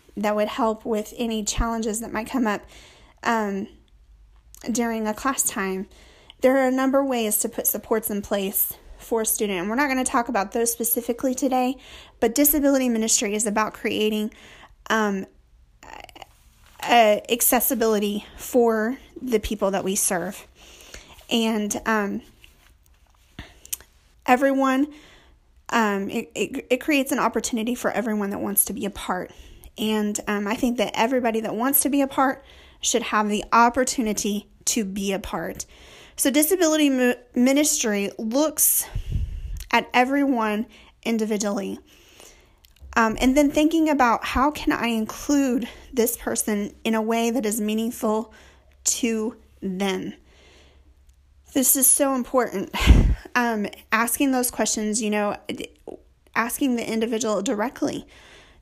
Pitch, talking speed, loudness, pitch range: 225 Hz, 135 wpm, -22 LUFS, 210-255 Hz